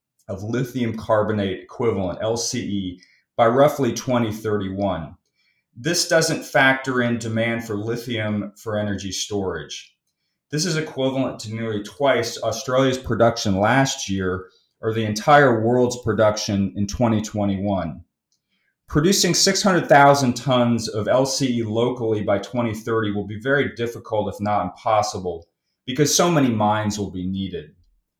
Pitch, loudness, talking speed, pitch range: 115 Hz, -21 LUFS, 120 wpm, 105-130 Hz